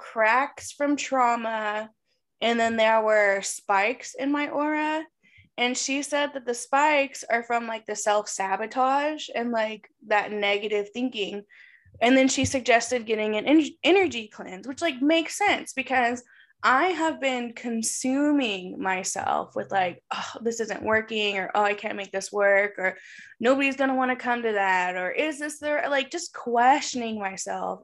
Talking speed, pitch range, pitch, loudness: 165 wpm, 210-275 Hz, 235 Hz, -25 LUFS